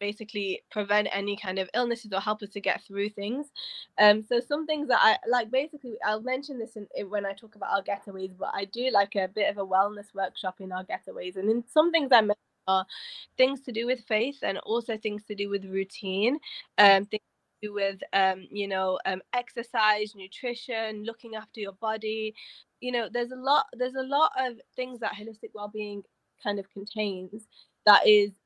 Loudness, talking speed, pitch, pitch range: -28 LUFS, 205 wpm, 210 Hz, 200-240 Hz